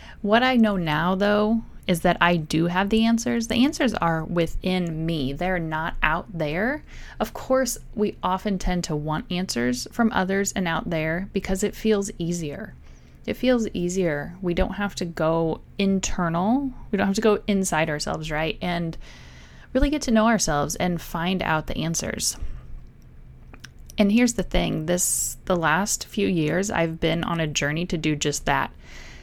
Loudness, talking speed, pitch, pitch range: -24 LUFS, 170 wpm, 180 Hz, 160-205 Hz